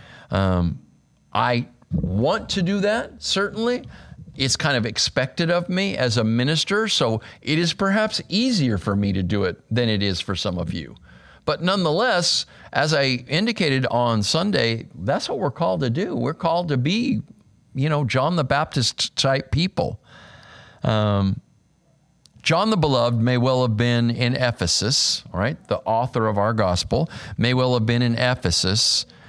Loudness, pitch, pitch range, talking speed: -21 LUFS, 125 Hz, 115-160 Hz, 160 wpm